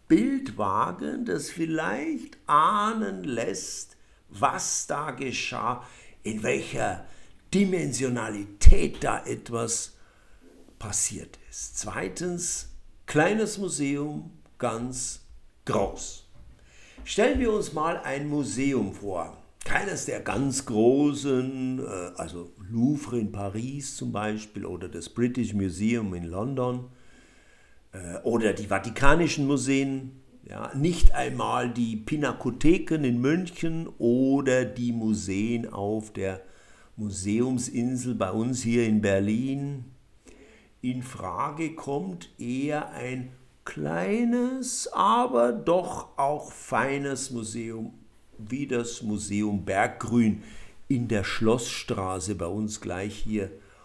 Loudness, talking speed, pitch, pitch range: -28 LUFS, 95 wpm, 125 Hz, 105-140 Hz